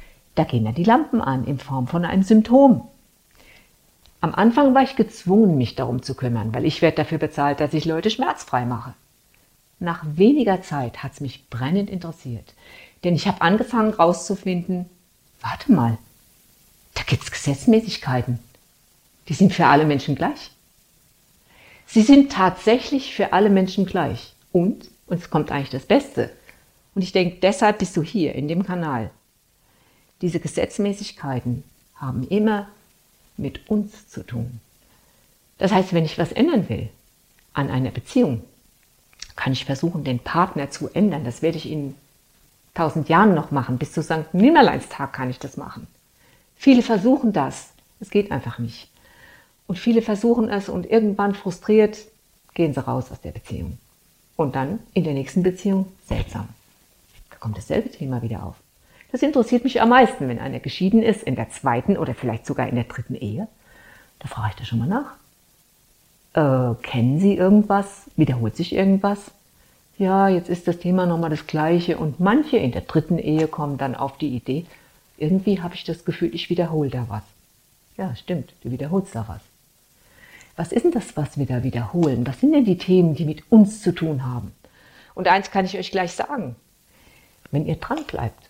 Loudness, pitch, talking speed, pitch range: -21 LUFS, 165 Hz, 170 wpm, 130-200 Hz